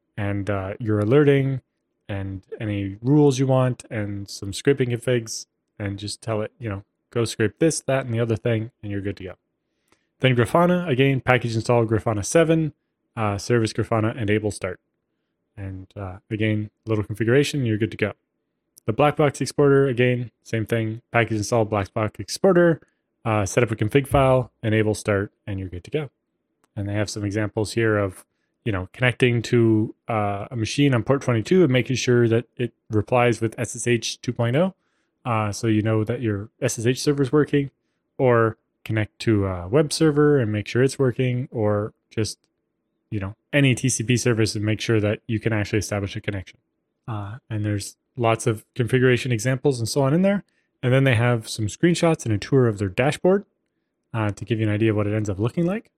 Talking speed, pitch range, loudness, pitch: 195 wpm, 105-130 Hz, -22 LUFS, 115 Hz